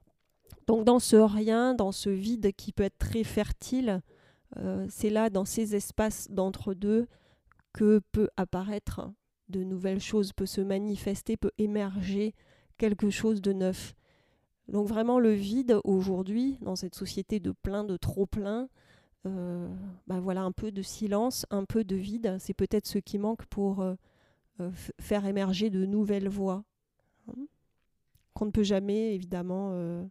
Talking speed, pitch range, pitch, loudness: 155 wpm, 190-215 Hz, 200 Hz, -30 LUFS